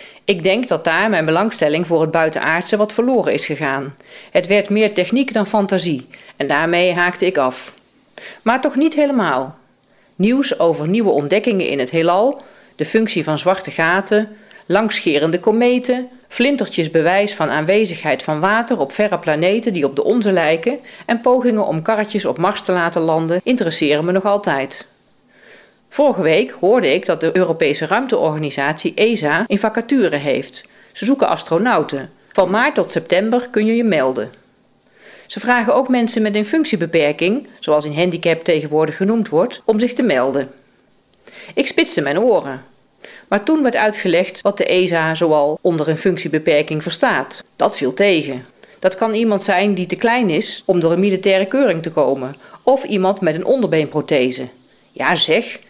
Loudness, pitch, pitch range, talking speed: -16 LUFS, 190 Hz, 160-220 Hz, 160 wpm